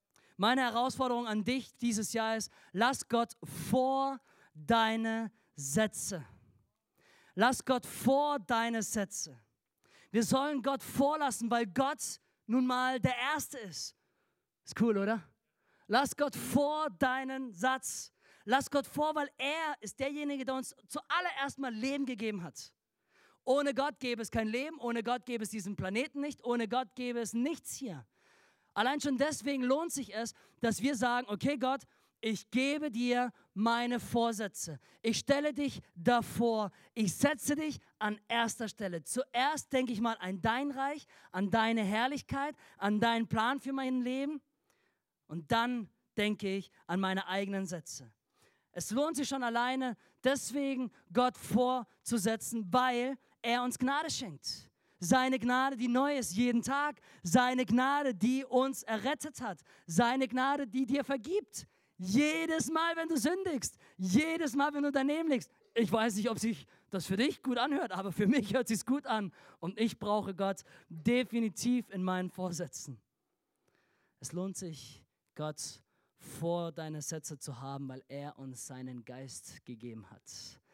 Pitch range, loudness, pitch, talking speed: 200-270 Hz, -34 LUFS, 240 Hz, 150 wpm